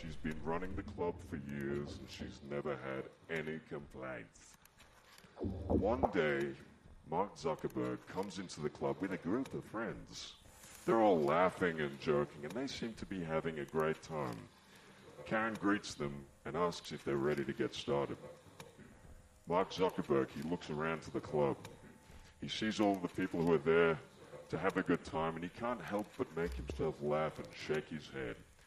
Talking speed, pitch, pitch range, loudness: 175 wpm, 80 Hz, 70-90 Hz, -38 LUFS